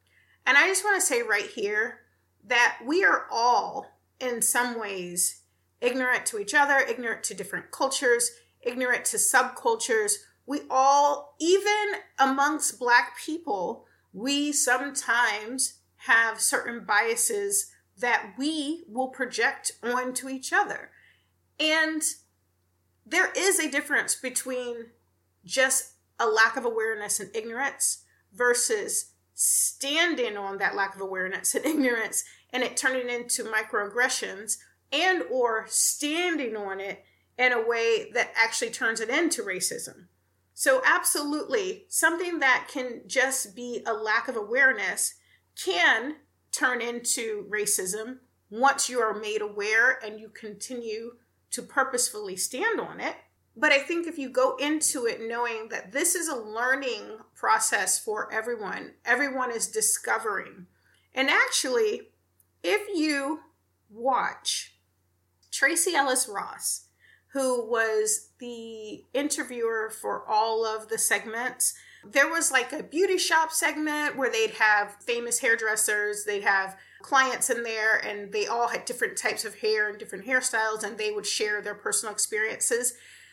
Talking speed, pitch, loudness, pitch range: 135 wpm, 255 Hz, -26 LUFS, 220-310 Hz